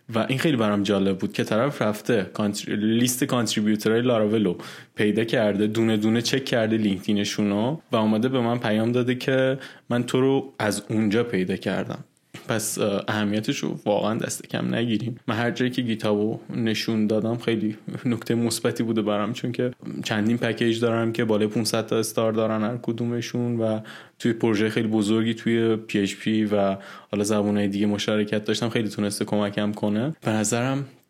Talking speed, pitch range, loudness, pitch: 165 wpm, 105-120 Hz, -24 LUFS, 110 Hz